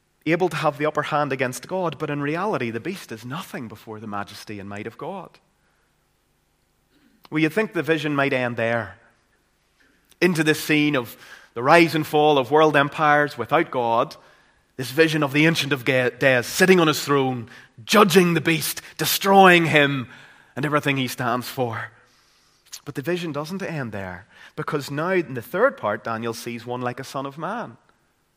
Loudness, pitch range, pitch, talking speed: -21 LUFS, 120-160 Hz, 145 Hz, 180 wpm